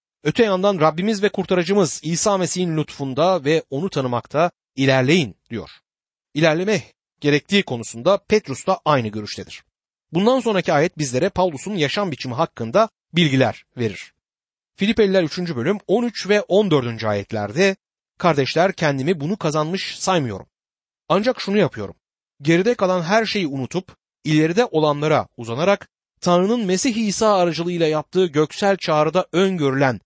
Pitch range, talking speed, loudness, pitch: 145-195 Hz, 120 wpm, -20 LUFS, 170 Hz